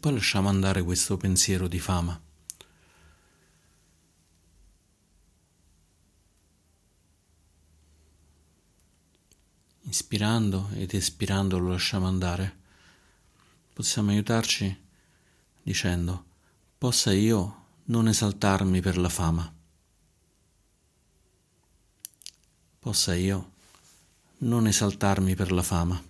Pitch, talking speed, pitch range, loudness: 90 Hz, 70 wpm, 85-100 Hz, -26 LUFS